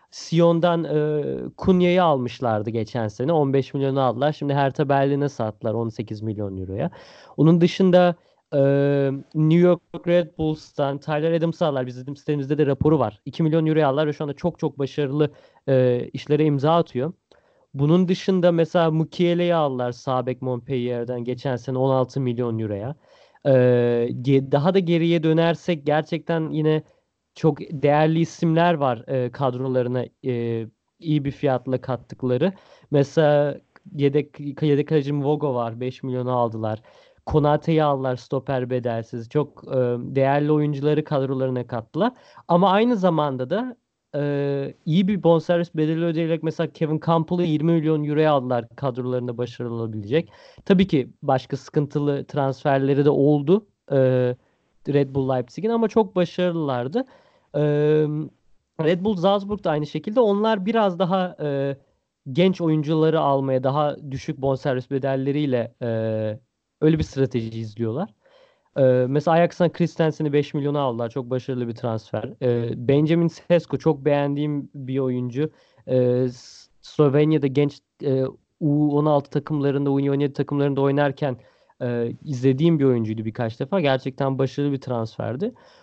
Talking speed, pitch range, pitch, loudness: 130 wpm, 130-160 Hz, 145 Hz, -22 LUFS